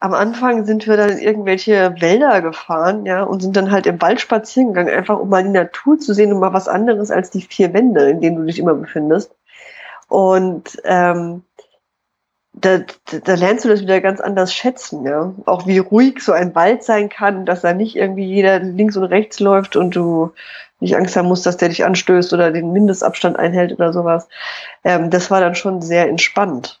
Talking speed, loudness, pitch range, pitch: 210 wpm, -15 LUFS, 175-205 Hz, 190 Hz